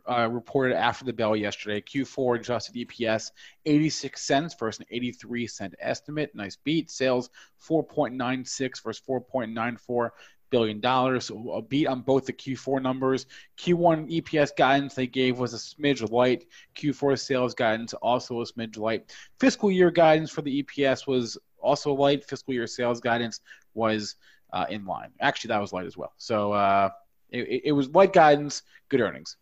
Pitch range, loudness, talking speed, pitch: 115-140 Hz, -26 LUFS, 165 wpm, 125 Hz